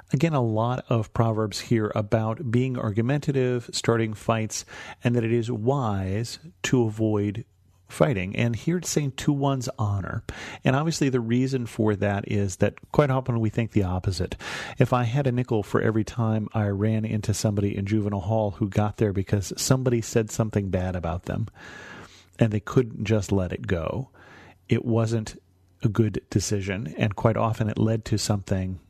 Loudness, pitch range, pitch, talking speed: -25 LUFS, 105-120 Hz, 110 Hz, 175 wpm